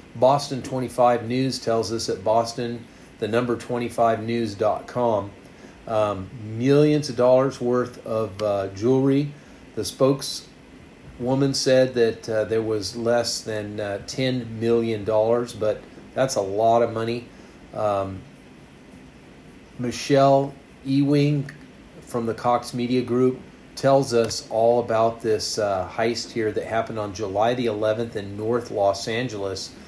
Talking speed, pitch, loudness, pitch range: 125 wpm, 115 Hz, -23 LUFS, 110-130 Hz